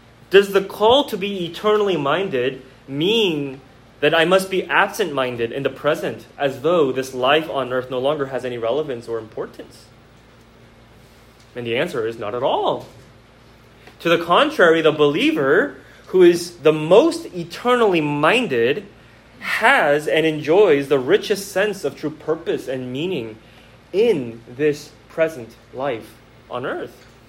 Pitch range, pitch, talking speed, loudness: 125-180 Hz, 150 Hz, 145 wpm, -19 LUFS